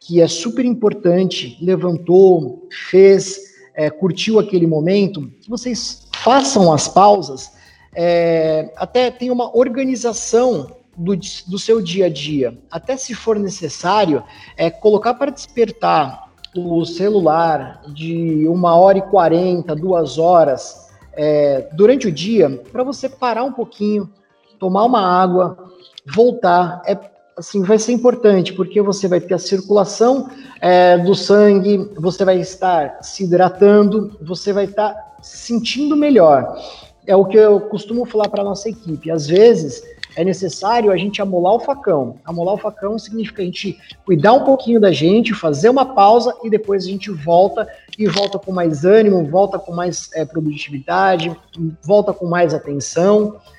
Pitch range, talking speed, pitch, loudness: 175-220 Hz, 150 wpm, 195 Hz, -15 LUFS